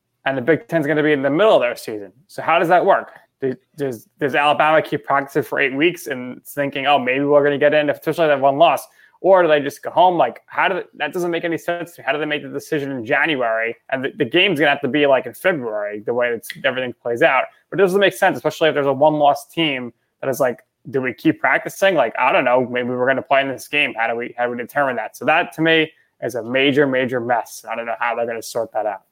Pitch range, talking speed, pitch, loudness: 125-155 Hz, 285 wpm, 140 Hz, -18 LUFS